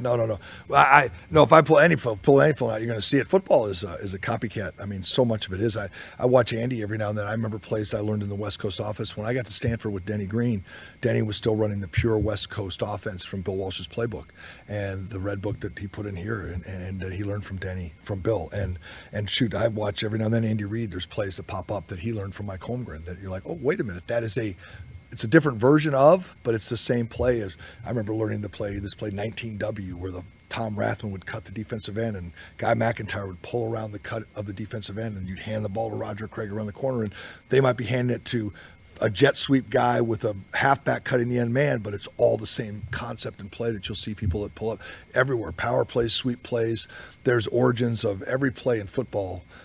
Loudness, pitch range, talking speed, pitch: -25 LUFS, 100-115 Hz, 260 wpm, 110 Hz